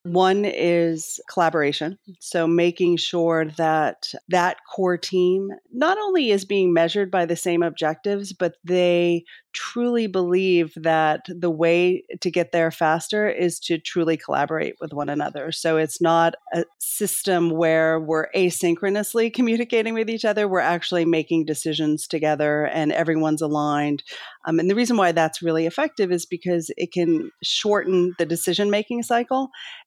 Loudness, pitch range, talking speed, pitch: -22 LUFS, 165-195 Hz, 150 wpm, 175 Hz